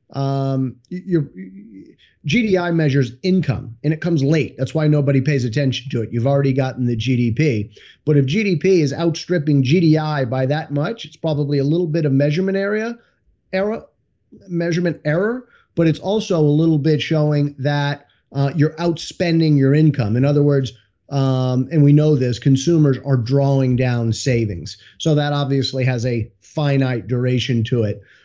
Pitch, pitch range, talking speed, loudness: 145 Hz, 130-160 Hz, 160 wpm, -18 LUFS